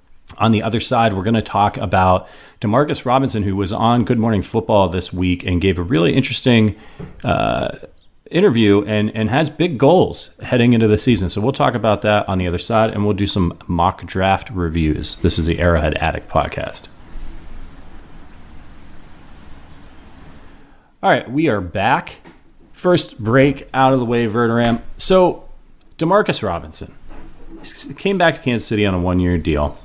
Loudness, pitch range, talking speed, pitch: -17 LUFS, 85-120 Hz, 165 wpm, 100 Hz